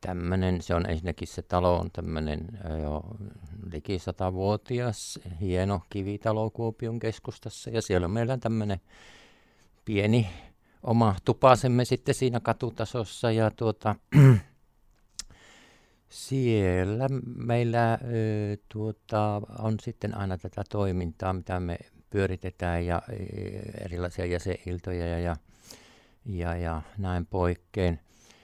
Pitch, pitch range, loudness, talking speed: 100 Hz, 90-115 Hz, -28 LUFS, 100 wpm